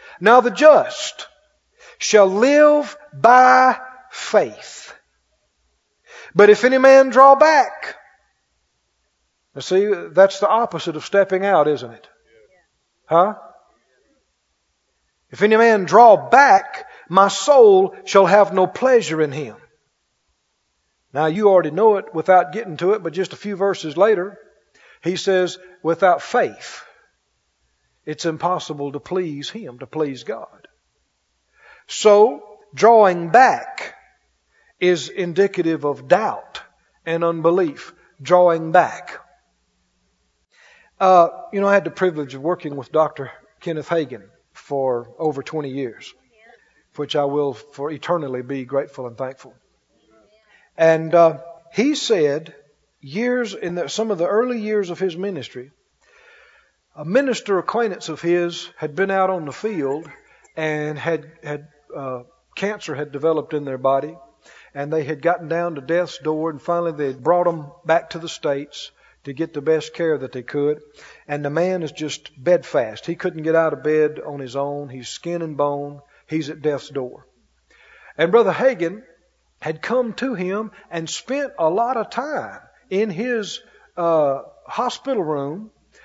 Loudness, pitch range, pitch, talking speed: -18 LUFS, 145-205 Hz, 170 Hz, 140 wpm